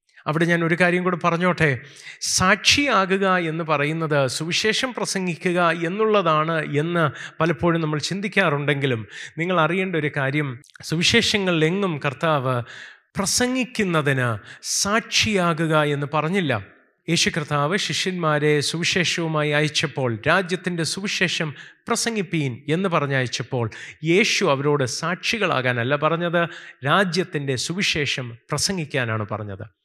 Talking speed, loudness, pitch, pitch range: 90 wpm, -21 LUFS, 160 Hz, 145-185 Hz